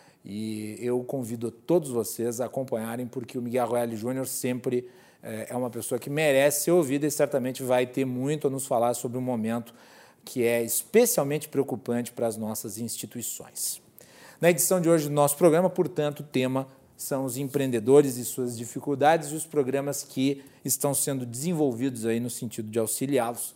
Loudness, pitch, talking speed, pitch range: -27 LUFS, 130 Hz, 175 wpm, 120-145 Hz